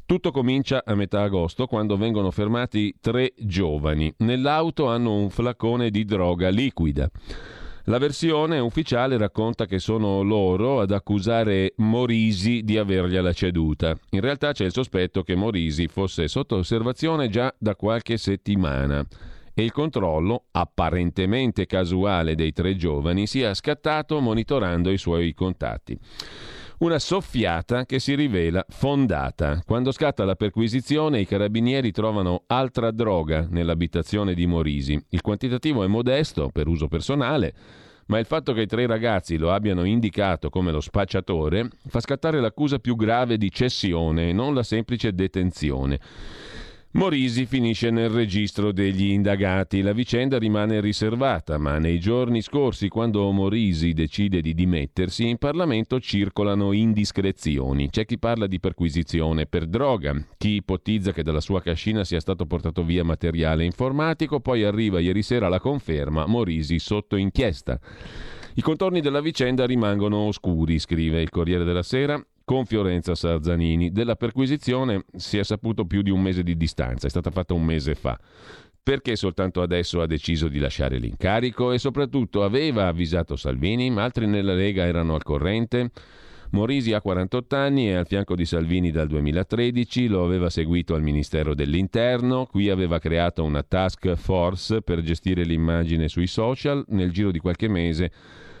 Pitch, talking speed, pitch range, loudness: 100 Hz, 150 wpm, 85-120 Hz, -23 LUFS